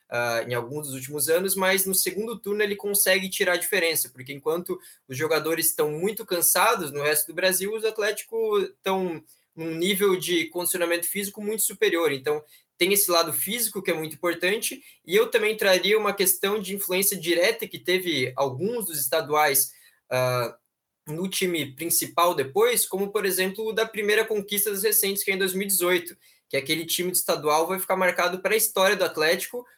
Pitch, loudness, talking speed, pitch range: 185 Hz, -24 LUFS, 175 wpm, 160-205 Hz